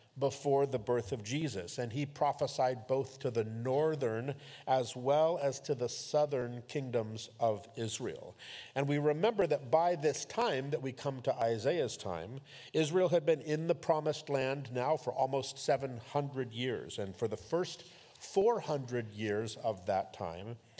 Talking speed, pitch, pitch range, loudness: 160 wpm, 135 Hz, 120-150 Hz, -35 LUFS